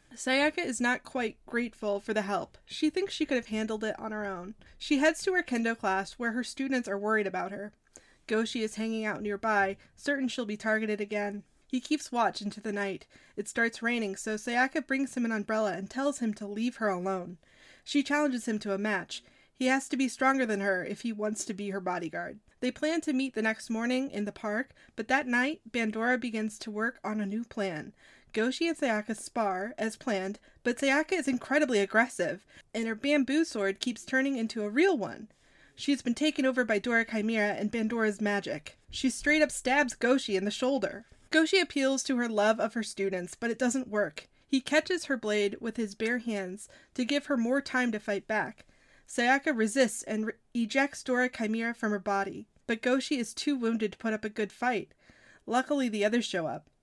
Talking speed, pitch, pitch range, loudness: 210 wpm, 230 Hz, 210-265 Hz, -30 LUFS